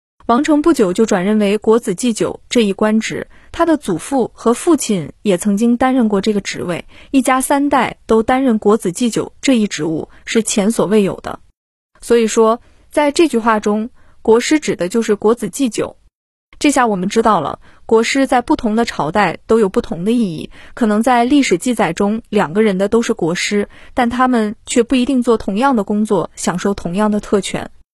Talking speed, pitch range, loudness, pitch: 280 characters per minute, 205-245 Hz, -15 LUFS, 225 Hz